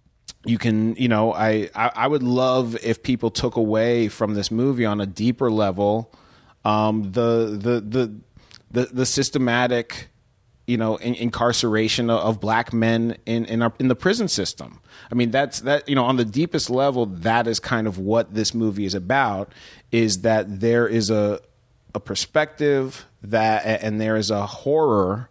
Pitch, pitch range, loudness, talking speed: 115 Hz, 110-125 Hz, -21 LUFS, 175 wpm